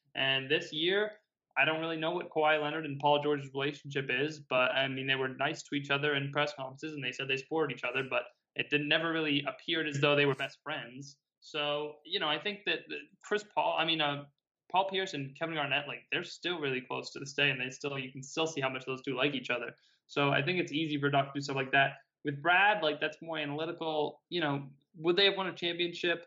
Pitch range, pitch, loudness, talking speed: 140-160 Hz, 145 Hz, -32 LUFS, 250 wpm